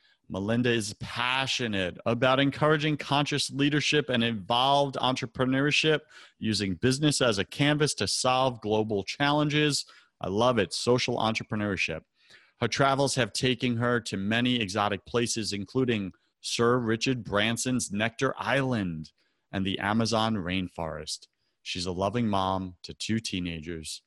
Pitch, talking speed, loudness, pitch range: 120 Hz, 125 wpm, -27 LUFS, 100-130 Hz